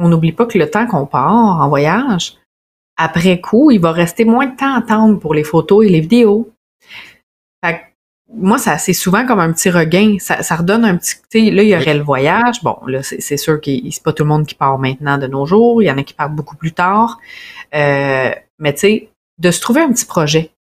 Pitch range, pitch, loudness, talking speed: 150-220 Hz, 180 Hz, -13 LUFS, 240 wpm